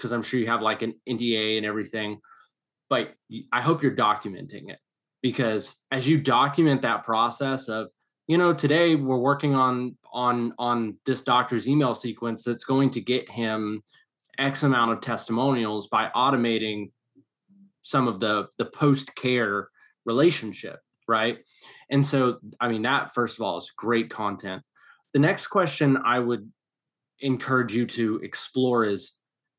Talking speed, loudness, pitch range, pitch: 150 wpm, -25 LUFS, 115-135 Hz, 125 Hz